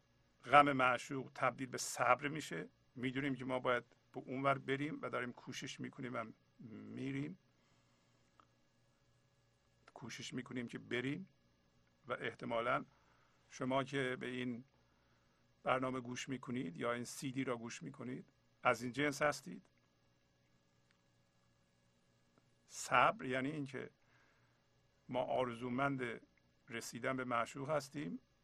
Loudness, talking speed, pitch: -40 LUFS, 110 wpm, 125 Hz